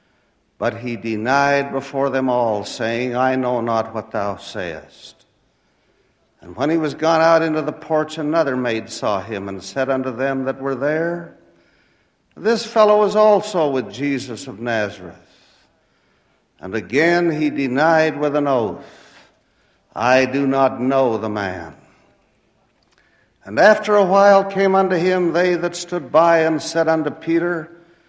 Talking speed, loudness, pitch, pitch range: 145 wpm, -18 LUFS, 140 Hz, 125-165 Hz